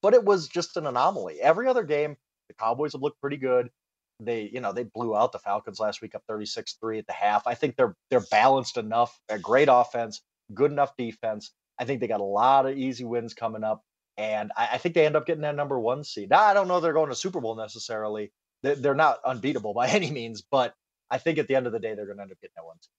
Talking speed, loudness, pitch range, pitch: 265 wpm, -26 LUFS, 110-150 Hz, 125 Hz